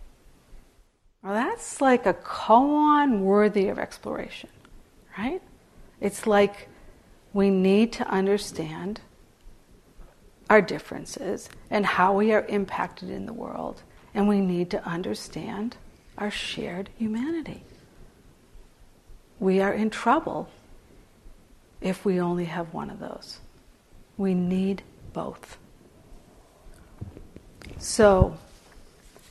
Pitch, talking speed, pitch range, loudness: 205 Hz, 100 wpm, 190-225 Hz, -25 LUFS